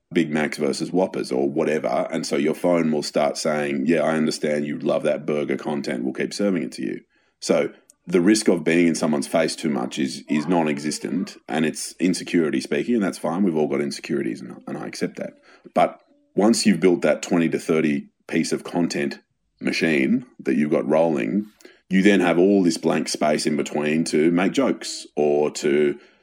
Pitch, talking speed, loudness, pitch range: 80 Hz, 195 wpm, -22 LUFS, 75-95 Hz